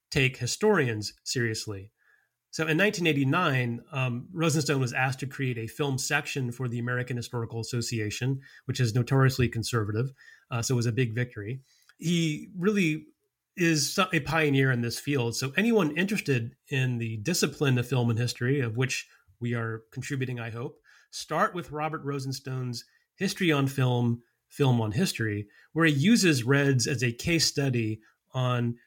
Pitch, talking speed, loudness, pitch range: 130 Hz, 155 wpm, -28 LUFS, 120-155 Hz